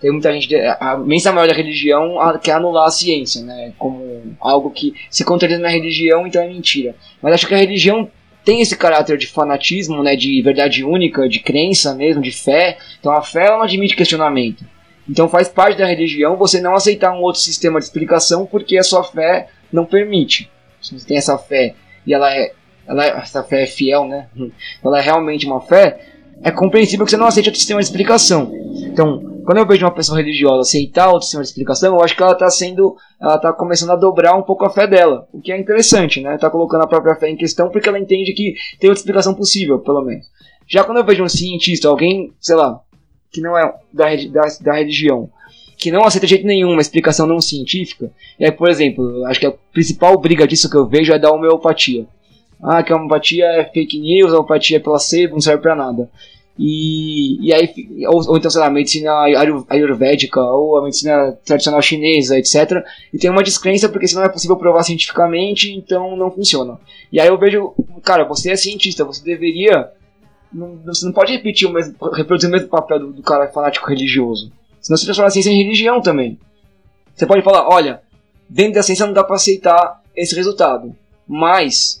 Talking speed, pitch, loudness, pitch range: 205 wpm, 165 Hz, -13 LUFS, 145-190 Hz